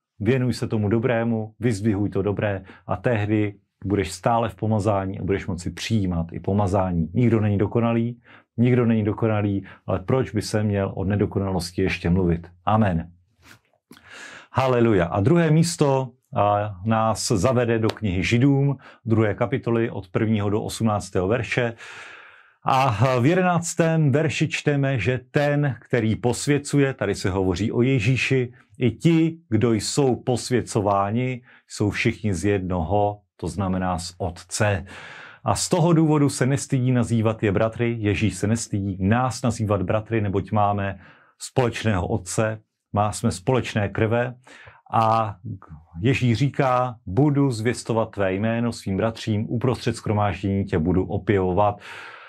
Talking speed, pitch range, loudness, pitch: 130 wpm, 100-125 Hz, -23 LUFS, 110 Hz